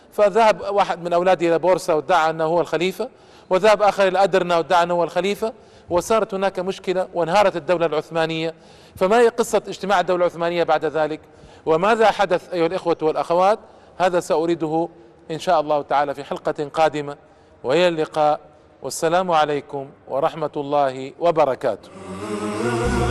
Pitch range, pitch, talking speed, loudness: 155-185 Hz, 165 Hz, 140 wpm, -20 LUFS